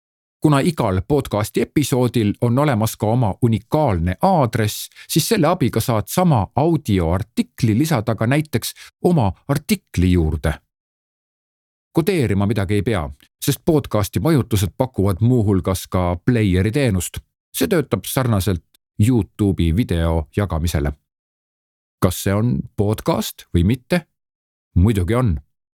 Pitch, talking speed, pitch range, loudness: 110 Hz, 110 wpm, 95-135 Hz, -19 LUFS